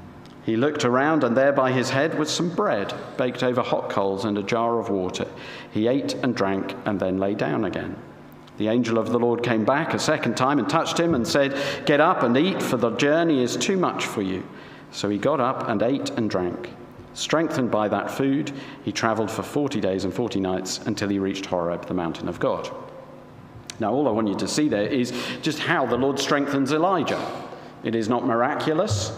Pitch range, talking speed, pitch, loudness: 105-140 Hz, 210 wpm, 120 Hz, -23 LUFS